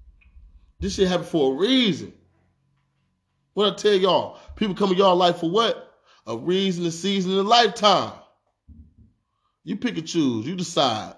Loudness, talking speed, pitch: -21 LUFS, 155 wpm, 170 Hz